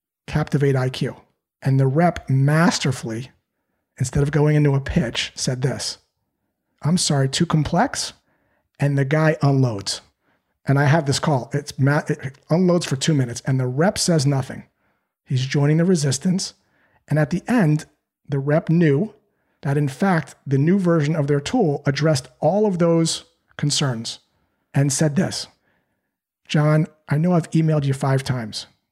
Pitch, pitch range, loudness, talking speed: 150 Hz, 140-165 Hz, -20 LUFS, 155 wpm